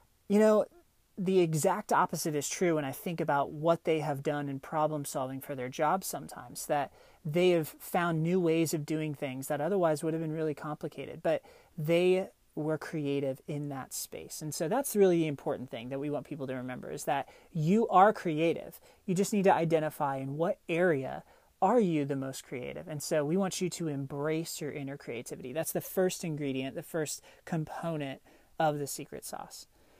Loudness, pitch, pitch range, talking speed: -32 LUFS, 160 Hz, 145-180 Hz, 195 wpm